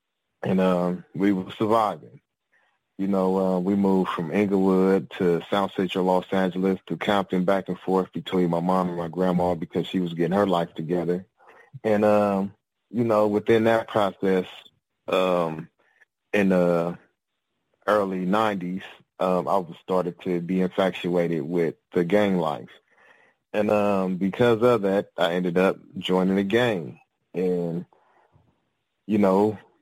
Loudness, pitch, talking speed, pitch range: -24 LUFS, 95 Hz, 145 wpm, 90-100 Hz